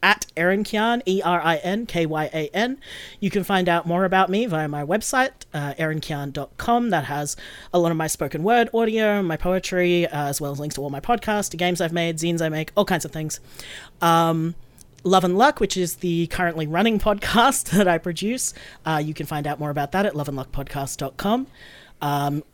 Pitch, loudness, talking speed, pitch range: 170 Hz, -22 LUFS, 210 wpm, 150-200 Hz